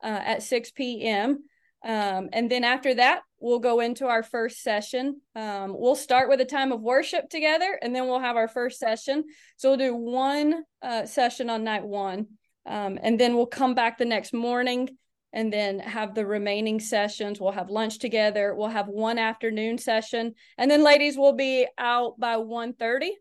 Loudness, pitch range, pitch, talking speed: -25 LUFS, 220-260 Hz, 240 Hz, 190 wpm